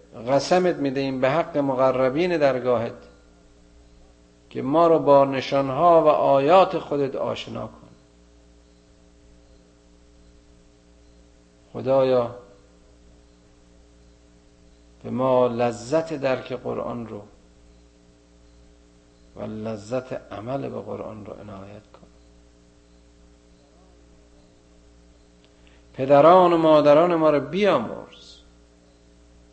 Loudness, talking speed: -21 LUFS, 75 wpm